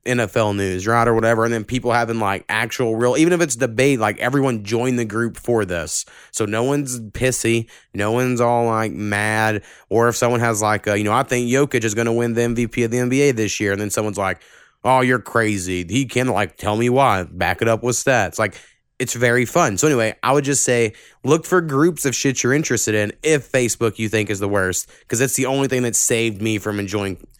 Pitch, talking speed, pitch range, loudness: 115 Hz, 230 wpm, 105-125 Hz, -19 LUFS